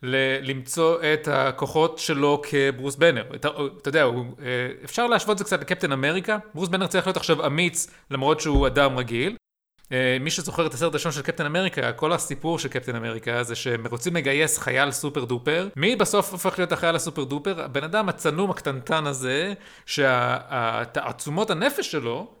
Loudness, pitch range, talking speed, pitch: -24 LUFS, 135-175 Hz, 170 wpm, 150 Hz